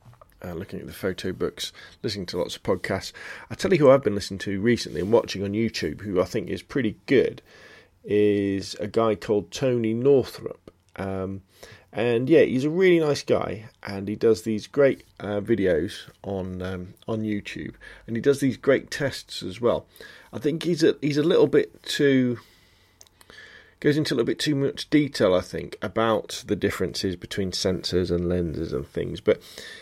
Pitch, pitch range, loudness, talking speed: 105 Hz, 95-130 Hz, -24 LUFS, 185 wpm